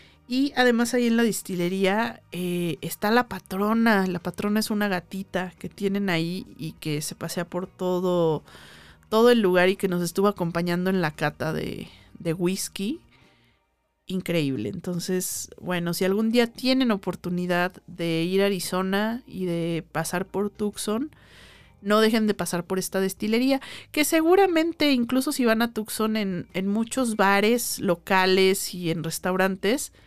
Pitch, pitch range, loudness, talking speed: 190 Hz, 175-220 Hz, -24 LUFS, 155 wpm